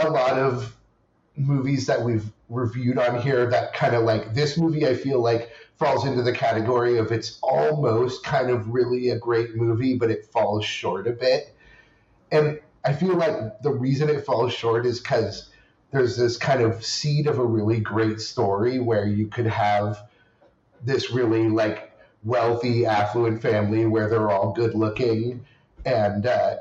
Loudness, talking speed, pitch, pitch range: -23 LUFS, 170 wpm, 120 Hz, 110-135 Hz